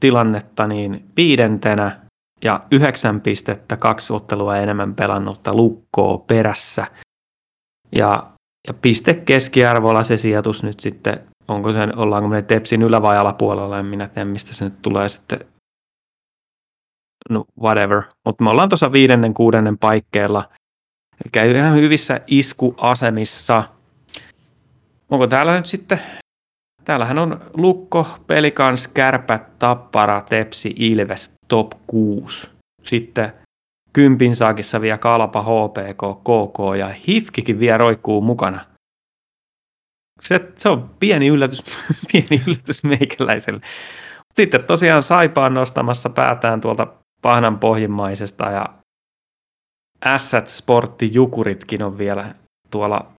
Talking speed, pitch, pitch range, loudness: 110 wpm, 115 Hz, 105-130 Hz, -17 LUFS